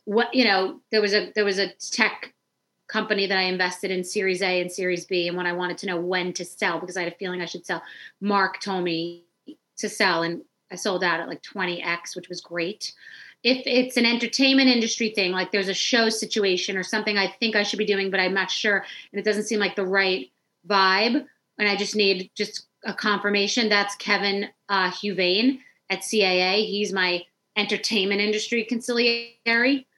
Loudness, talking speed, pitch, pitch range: -23 LUFS, 200 wpm, 200 Hz, 185-215 Hz